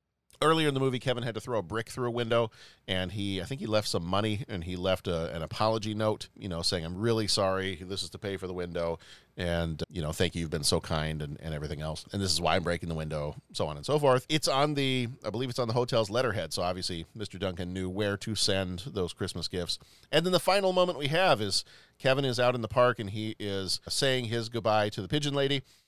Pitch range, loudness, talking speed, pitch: 90-120 Hz, -30 LUFS, 260 wpm, 105 Hz